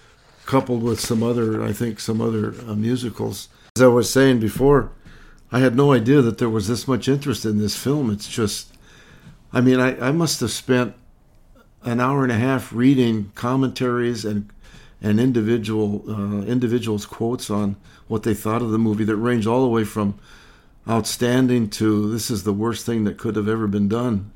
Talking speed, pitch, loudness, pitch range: 185 wpm, 115 Hz, -20 LUFS, 105-125 Hz